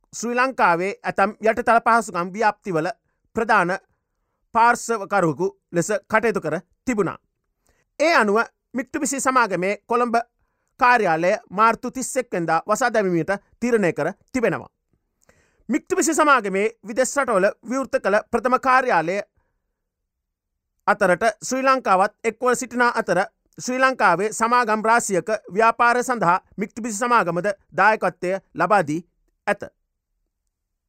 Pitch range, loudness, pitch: 190-245 Hz, -21 LUFS, 220 Hz